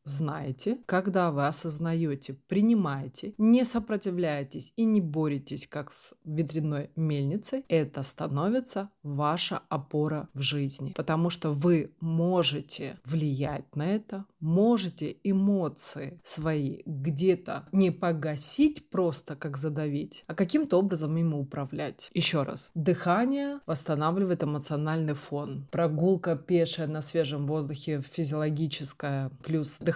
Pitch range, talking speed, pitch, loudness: 145-180 Hz, 110 wpm, 160 Hz, -29 LUFS